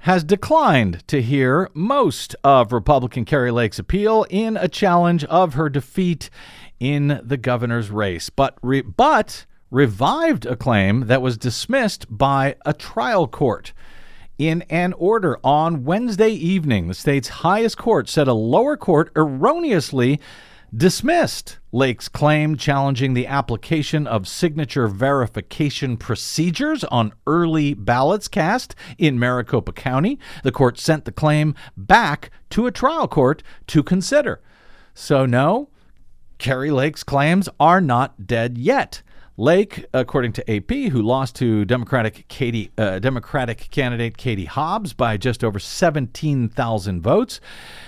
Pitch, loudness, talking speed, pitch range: 135 Hz, -19 LUFS, 130 wpm, 120-160 Hz